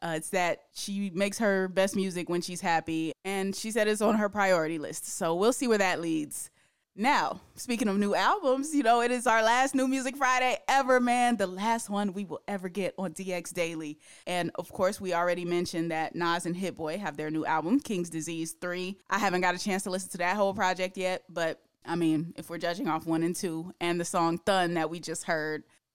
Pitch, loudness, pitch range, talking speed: 185 Hz, -29 LUFS, 165-205 Hz, 225 wpm